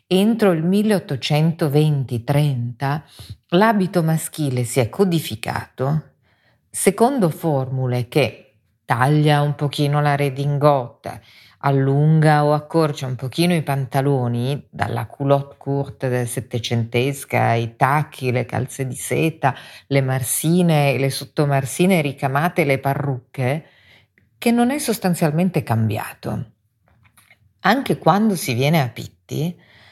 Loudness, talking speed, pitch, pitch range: -19 LUFS, 105 wpm, 140 Hz, 125-160 Hz